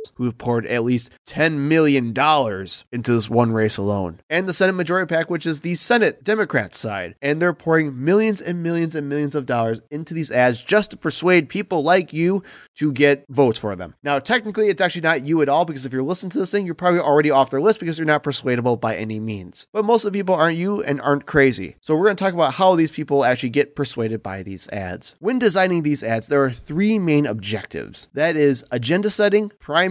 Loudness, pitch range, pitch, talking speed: -20 LUFS, 125-180 Hz, 150 Hz, 230 wpm